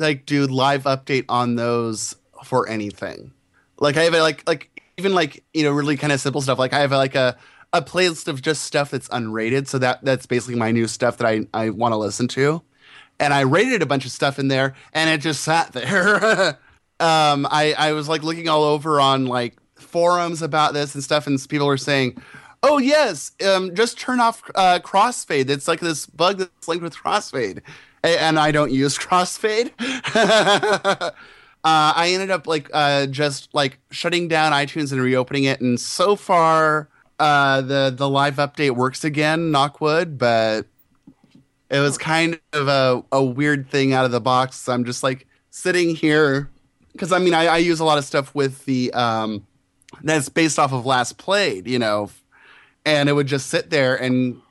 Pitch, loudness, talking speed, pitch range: 145 Hz, -19 LUFS, 195 wpm, 130-165 Hz